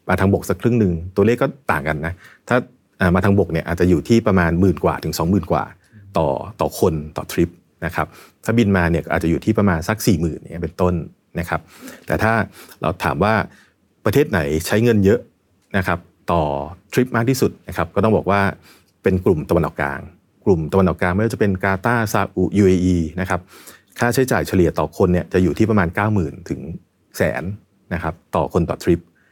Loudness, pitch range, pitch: -19 LUFS, 85-100 Hz, 90 Hz